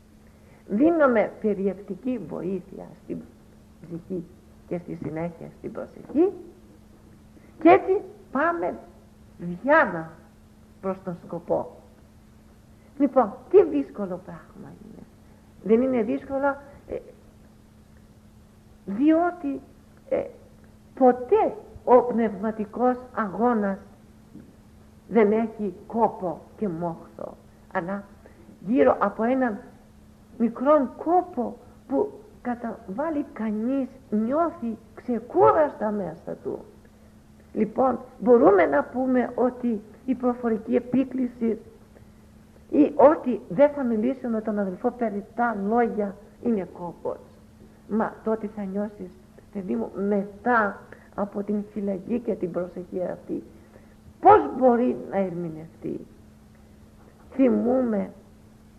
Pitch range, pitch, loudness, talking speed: 200-260 Hz, 225 Hz, -24 LUFS, 90 wpm